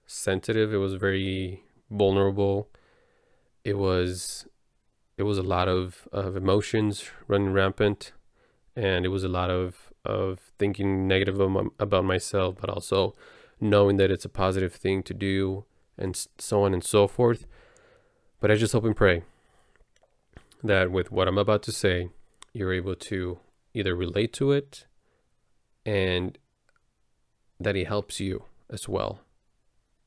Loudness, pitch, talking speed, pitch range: -26 LUFS, 95 Hz, 140 wpm, 95-105 Hz